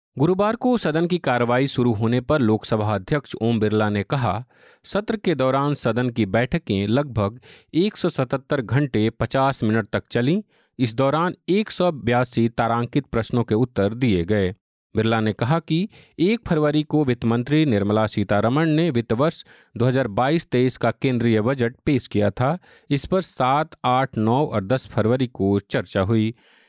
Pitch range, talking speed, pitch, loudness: 110-150 Hz, 155 wpm, 125 Hz, -22 LUFS